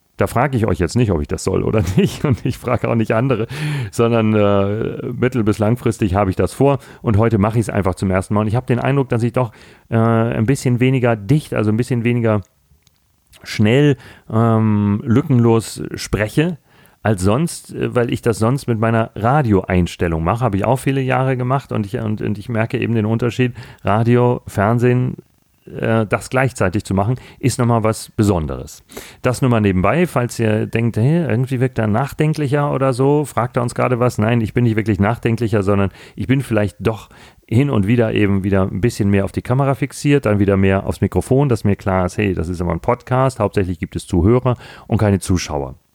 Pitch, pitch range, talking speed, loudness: 115 Hz, 105-125 Hz, 205 wpm, -17 LUFS